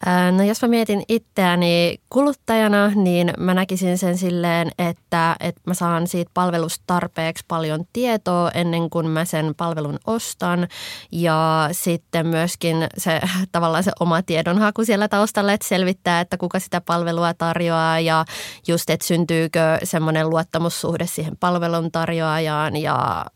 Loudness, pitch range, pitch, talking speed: -20 LUFS, 165-185 Hz, 170 Hz, 135 wpm